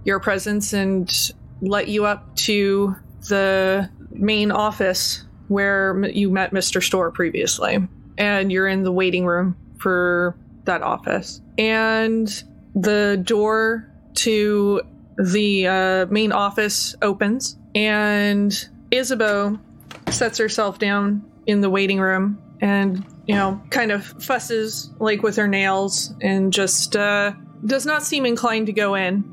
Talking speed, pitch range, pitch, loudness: 130 wpm, 190-215 Hz, 200 Hz, -20 LUFS